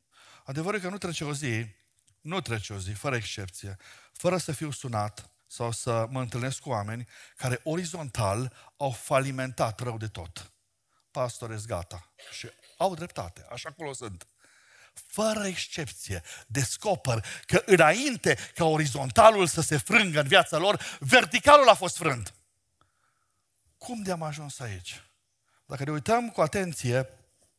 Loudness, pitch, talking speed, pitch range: -26 LUFS, 130 Hz, 140 wpm, 110-165 Hz